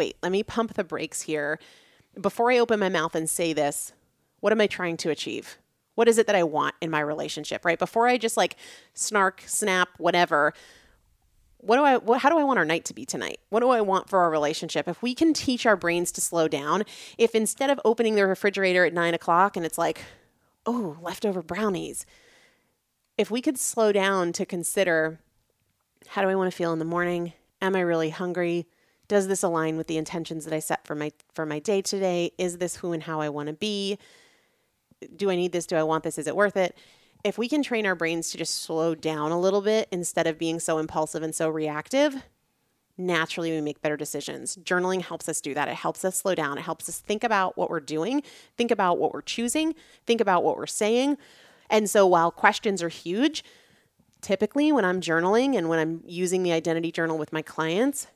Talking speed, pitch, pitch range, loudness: 220 wpm, 180 Hz, 165-215 Hz, -25 LUFS